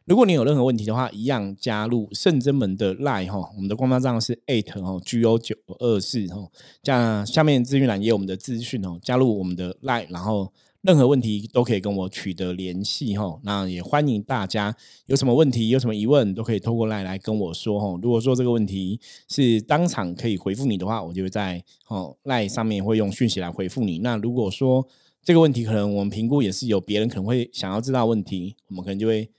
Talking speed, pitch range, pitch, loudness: 370 characters per minute, 95-125 Hz, 110 Hz, -23 LUFS